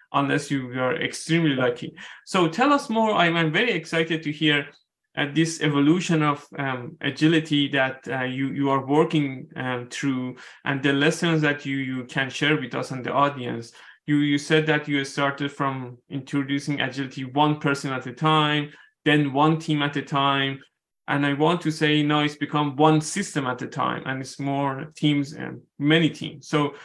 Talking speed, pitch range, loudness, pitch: 190 wpm, 135-155 Hz, -23 LUFS, 145 Hz